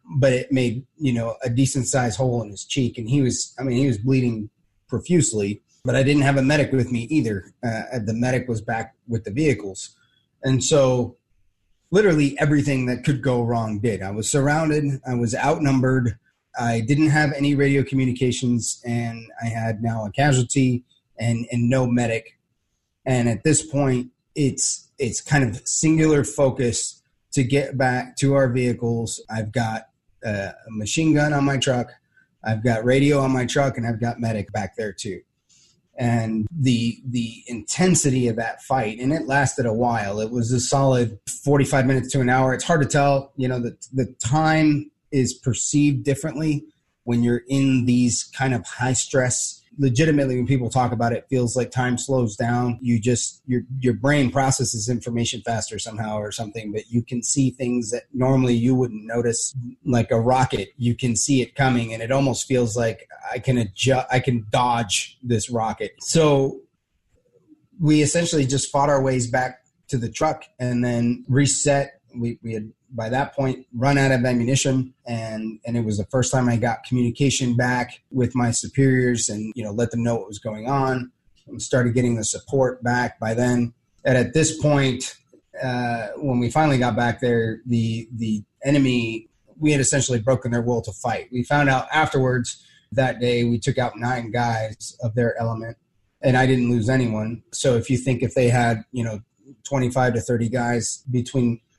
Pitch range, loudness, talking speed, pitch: 115-135 Hz, -22 LUFS, 185 wpm, 125 Hz